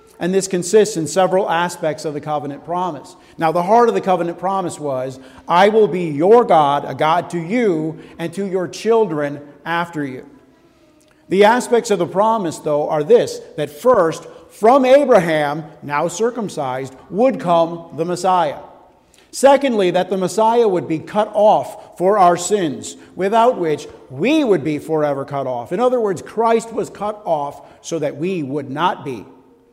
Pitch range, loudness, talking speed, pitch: 155-215 Hz, -17 LUFS, 170 wpm, 175 Hz